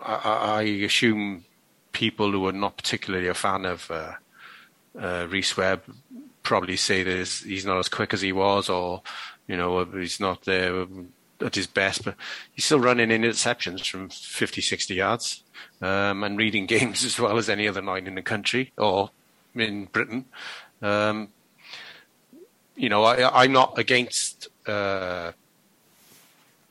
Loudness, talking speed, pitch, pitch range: -24 LUFS, 150 wpm, 100 Hz, 95-110 Hz